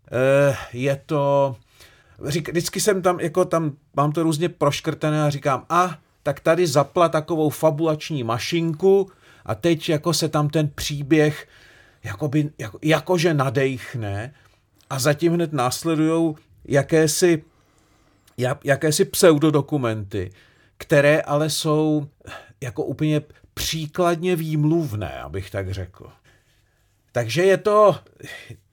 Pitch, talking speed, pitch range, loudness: 150 Hz, 110 wpm, 125-165 Hz, -21 LUFS